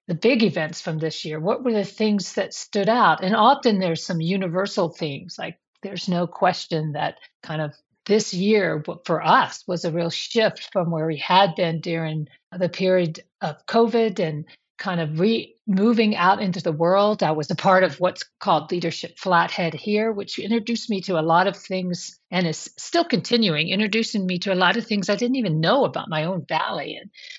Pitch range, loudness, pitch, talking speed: 165-210 Hz, -22 LUFS, 185 Hz, 200 wpm